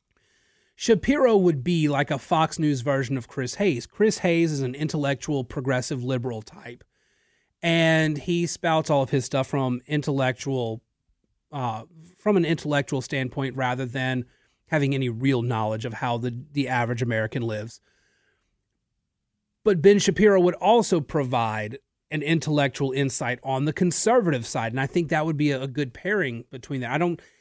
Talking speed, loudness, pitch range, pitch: 160 wpm, -24 LUFS, 130-165 Hz, 140 Hz